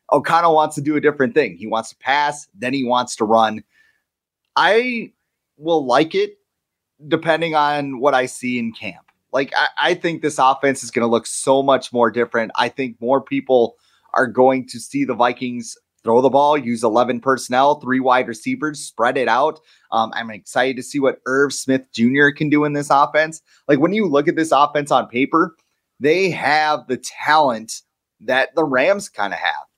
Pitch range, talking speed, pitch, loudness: 125-150 Hz, 195 wpm, 135 Hz, -18 LUFS